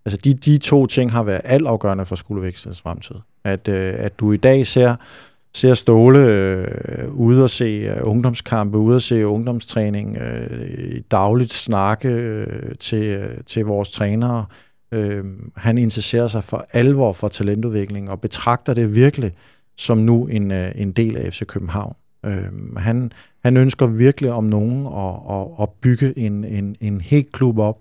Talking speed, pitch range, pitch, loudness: 160 wpm, 100-125 Hz, 110 Hz, -18 LUFS